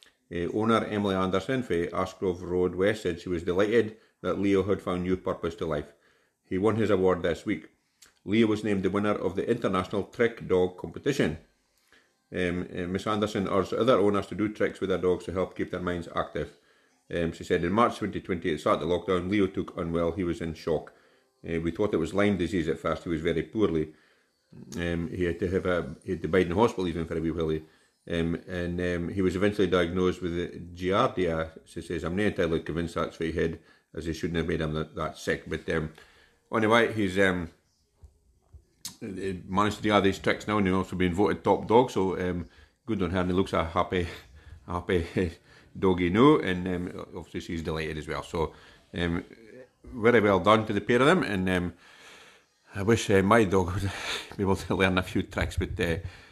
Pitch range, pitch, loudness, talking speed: 85-100 Hz, 90 Hz, -28 LUFS, 210 wpm